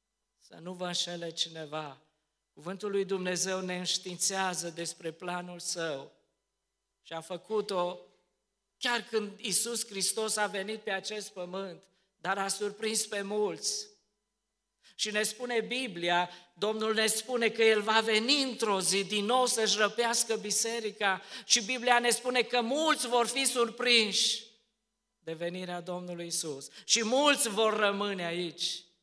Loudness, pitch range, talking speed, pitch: -30 LUFS, 180-225 Hz, 135 wpm, 205 Hz